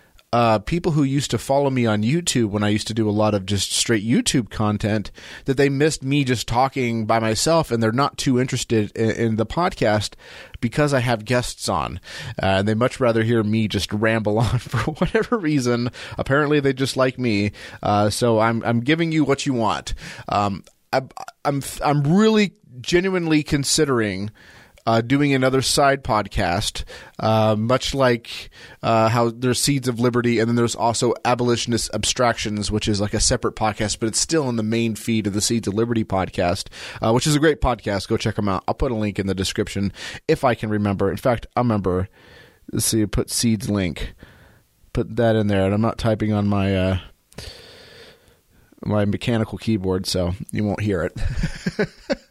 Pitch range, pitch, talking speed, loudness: 105-130 Hz, 115 Hz, 190 wpm, -21 LUFS